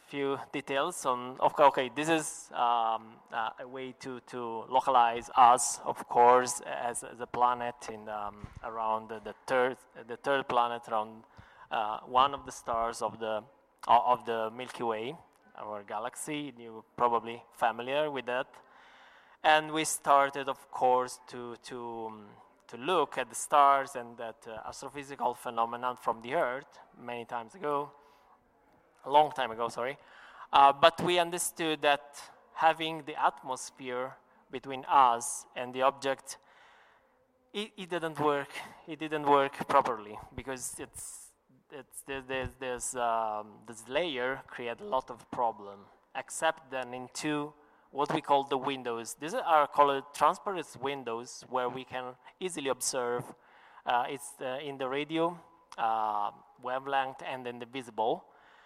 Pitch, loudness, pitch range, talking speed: 130 Hz, -31 LUFS, 120-145 Hz, 145 wpm